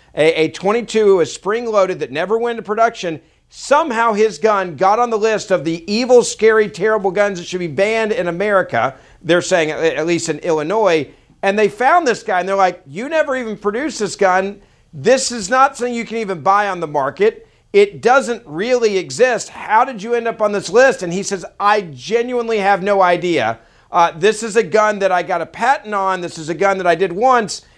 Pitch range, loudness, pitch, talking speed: 180-235 Hz, -16 LUFS, 205 Hz, 210 wpm